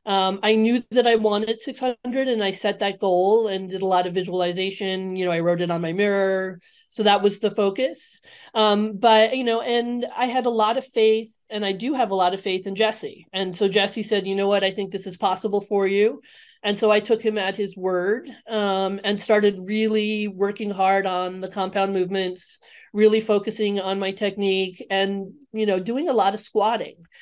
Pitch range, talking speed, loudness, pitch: 190-220 Hz, 215 wpm, -22 LUFS, 205 Hz